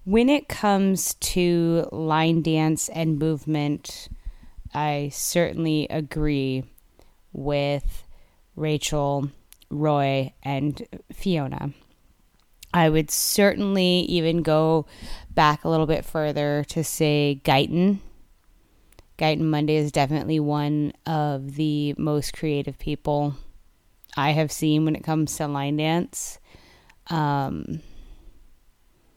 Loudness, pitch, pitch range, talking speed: -23 LUFS, 150 Hz, 140-160 Hz, 100 wpm